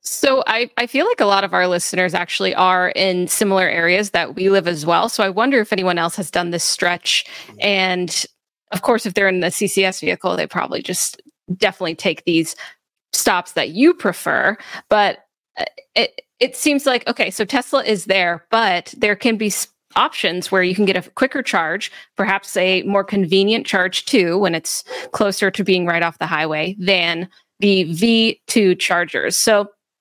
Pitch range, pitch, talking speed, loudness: 180-220 Hz, 195 Hz, 180 wpm, -17 LUFS